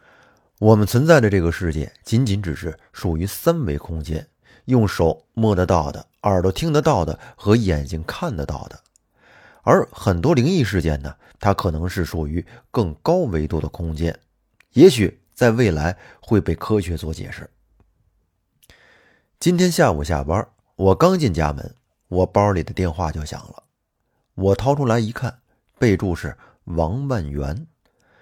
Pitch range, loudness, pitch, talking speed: 80-115 Hz, -20 LUFS, 95 Hz, 220 characters per minute